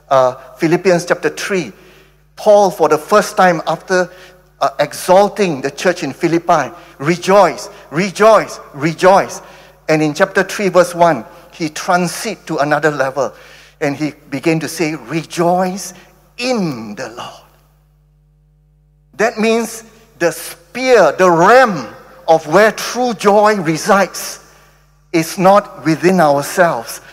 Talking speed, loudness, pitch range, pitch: 120 wpm, -14 LUFS, 155-195 Hz, 175 Hz